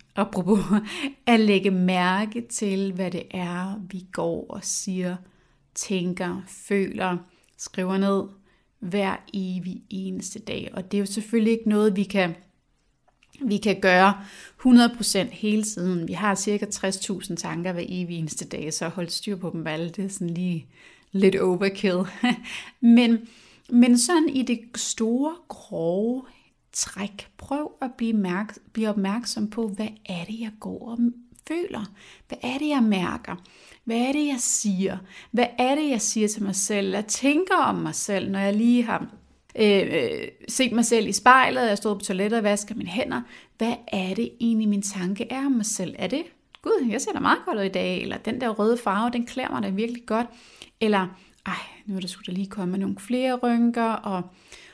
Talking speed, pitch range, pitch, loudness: 180 wpm, 190-235 Hz, 205 Hz, -24 LUFS